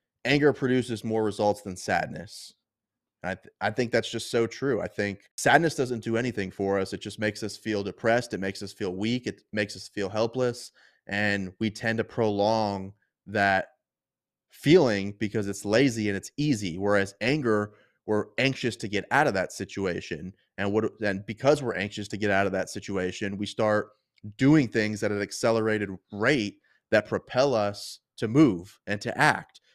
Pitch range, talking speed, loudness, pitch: 100-115 Hz, 180 wpm, -27 LUFS, 105 Hz